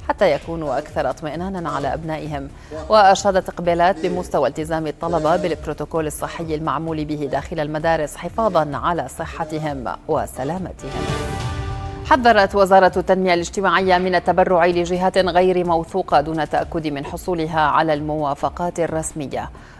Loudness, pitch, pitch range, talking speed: -19 LUFS, 165 Hz, 150-185 Hz, 110 wpm